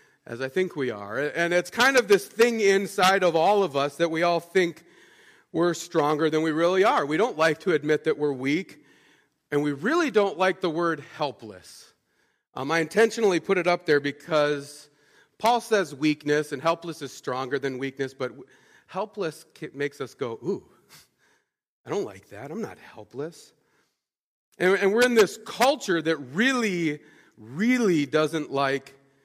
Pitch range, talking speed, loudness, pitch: 145-195 Hz, 170 wpm, -24 LUFS, 165 Hz